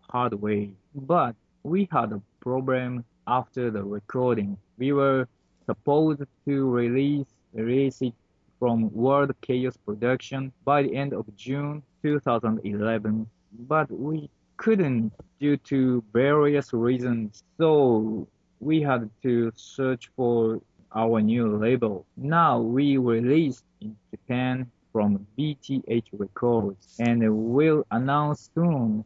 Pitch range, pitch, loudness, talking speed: 110-140 Hz, 125 Hz, -25 LUFS, 115 wpm